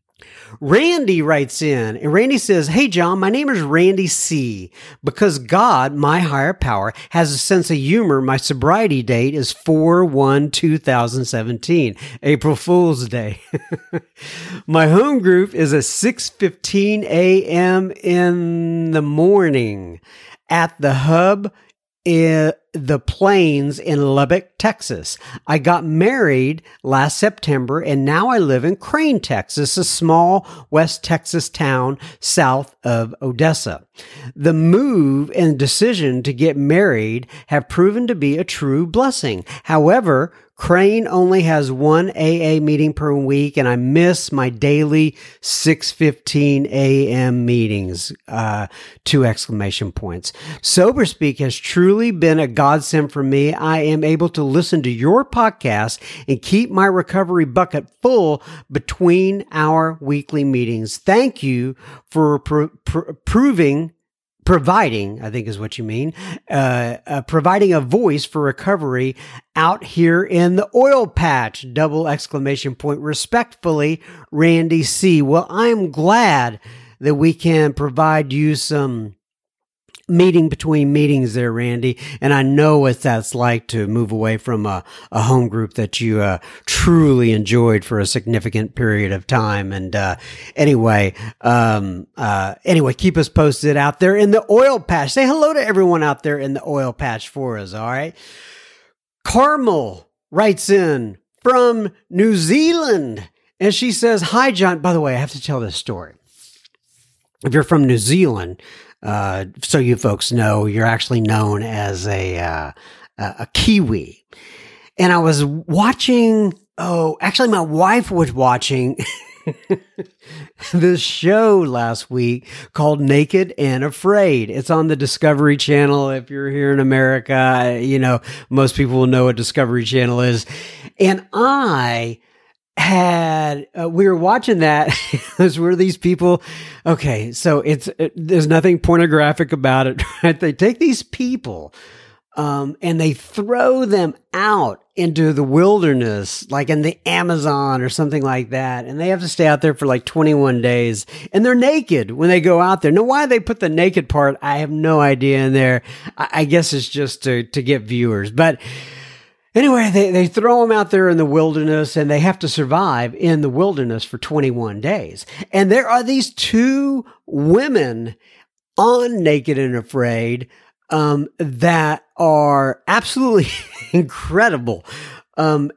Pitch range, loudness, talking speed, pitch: 130-180 Hz, -16 LUFS, 150 wpm, 150 Hz